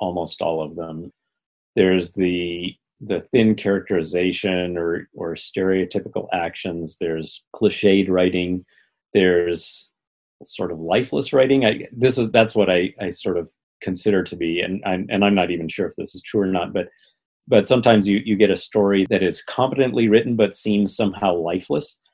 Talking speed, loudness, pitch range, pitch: 170 wpm, -20 LUFS, 90-105 Hz, 95 Hz